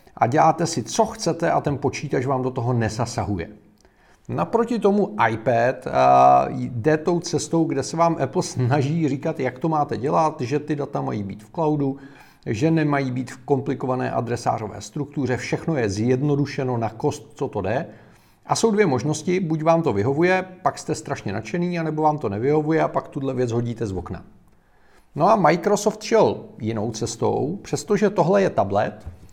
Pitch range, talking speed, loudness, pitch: 120-160 Hz, 170 wpm, -22 LUFS, 140 Hz